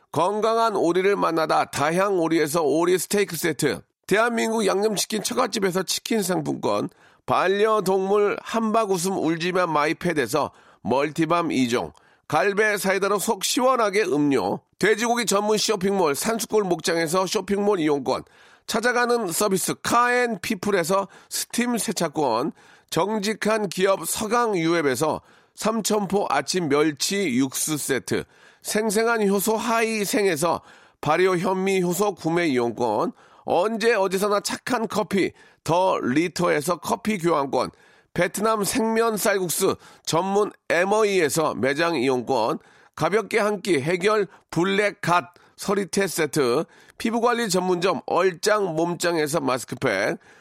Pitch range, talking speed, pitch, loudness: 175-220 Hz, 275 characters per minute, 200 Hz, -23 LUFS